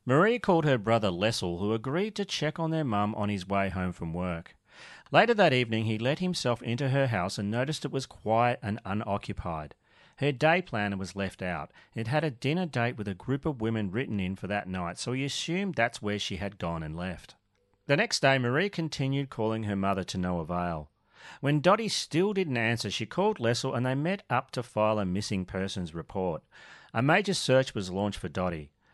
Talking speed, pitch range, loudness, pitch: 210 wpm, 100-140 Hz, -29 LUFS, 110 Hz